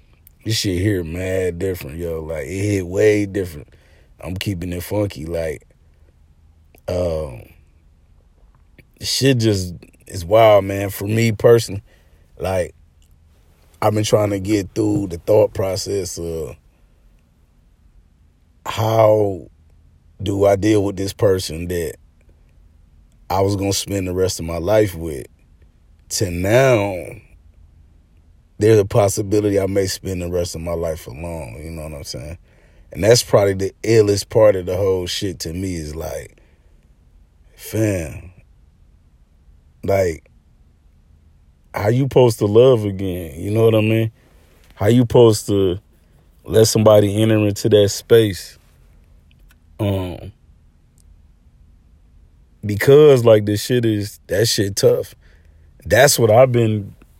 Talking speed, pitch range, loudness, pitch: 130 wpm, 80-105 Hz, -17 LUFS, 90 Hz